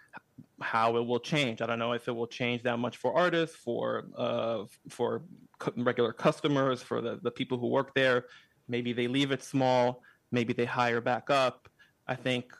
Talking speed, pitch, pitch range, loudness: 185 wpm, 125 Hz, 120-130 Hz, -30 LUFS